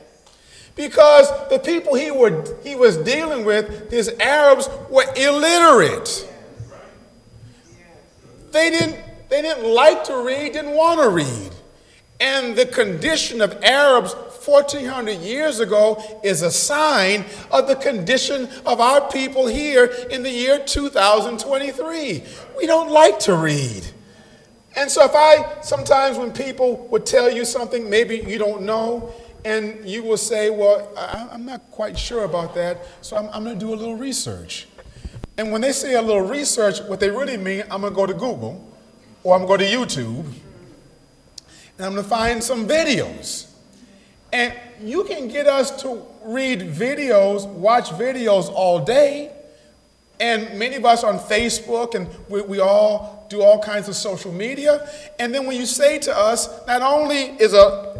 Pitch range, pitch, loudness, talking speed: 210-280 Hz, 240 Hz, -18 LUFS, 160 wpm